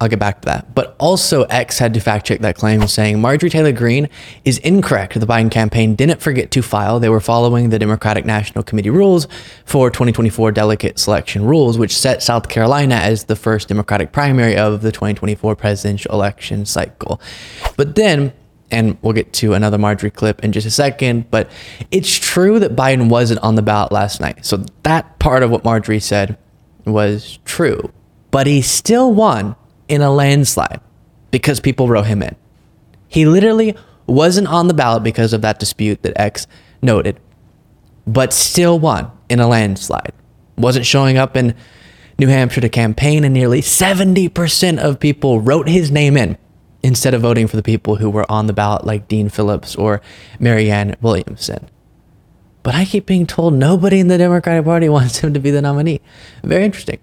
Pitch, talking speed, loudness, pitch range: 120 Hz, 180 wpm, -14 LUFS, 105-145 Hz